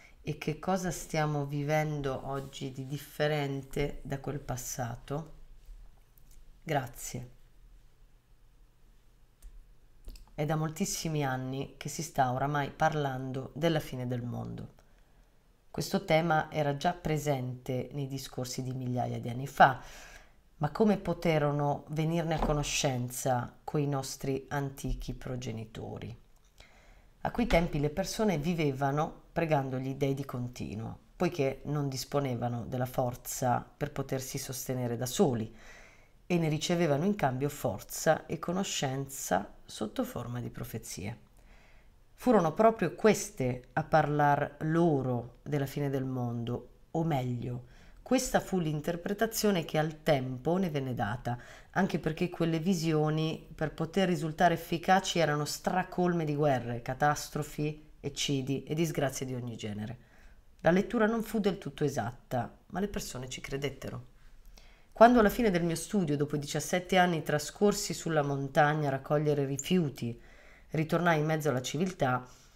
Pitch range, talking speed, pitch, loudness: 130-165 Hz, 125 wpm, 145 Hz, -31 LUFS